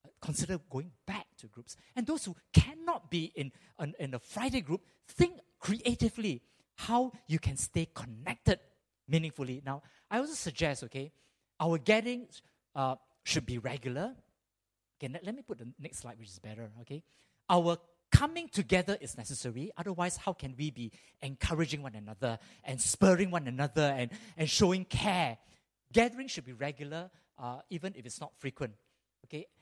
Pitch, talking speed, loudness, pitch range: 150 Hz, 155 wpm, -34 LUFS, 130-180 Hz